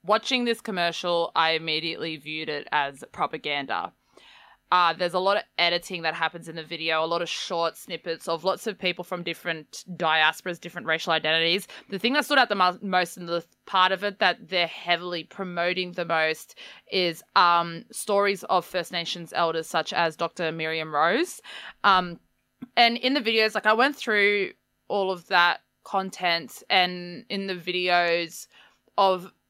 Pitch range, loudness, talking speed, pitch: 165-195 Hz, -25 LUFS, 175 wpm, 175 Hz